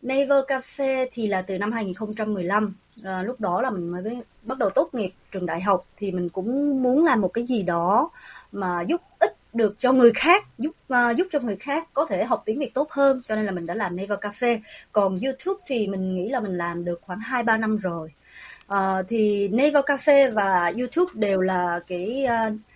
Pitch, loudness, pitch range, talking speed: 220 Hz, -24 LUFS, 190-265 Hz, 210 wpm